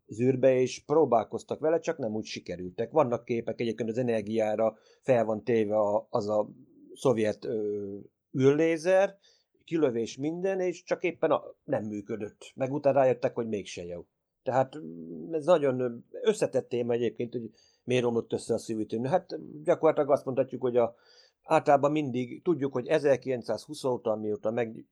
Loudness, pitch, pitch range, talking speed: -29 LUFS, 125 Hz, 110-150 Hz, 150 wpm